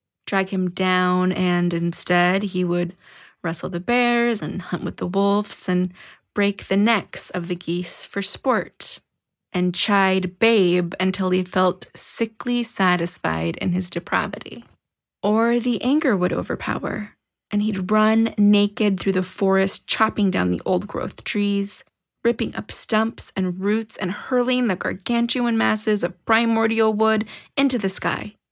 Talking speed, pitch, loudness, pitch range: 145 wpm, 195 Hz, -21 LUFS, 180-225 Hz